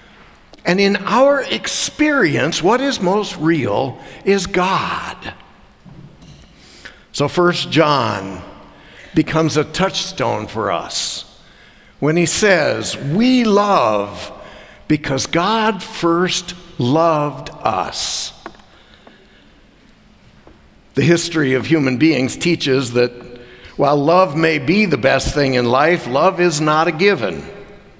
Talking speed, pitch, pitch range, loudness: 105 wpm, 165 Hz, 135-190 Hz, -16 LUFS